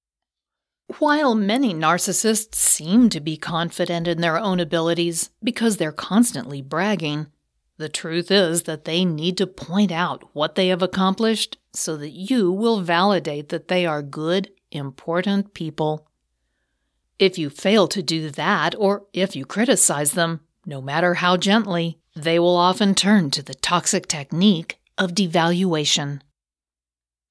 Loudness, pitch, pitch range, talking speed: -20 LUFS, 175 Hz, 155-195 Hz, 140 wpm